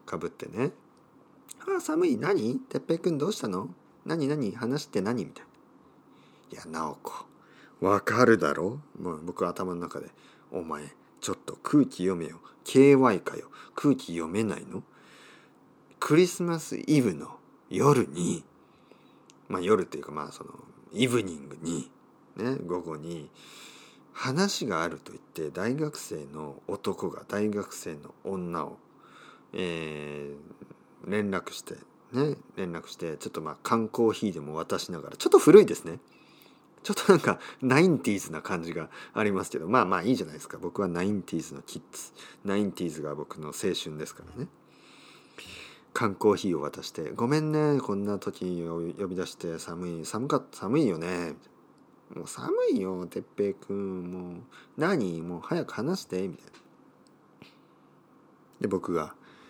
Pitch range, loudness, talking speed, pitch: 85-135 Hz, -29 LUFS, 280 characters per minute, 95 Hz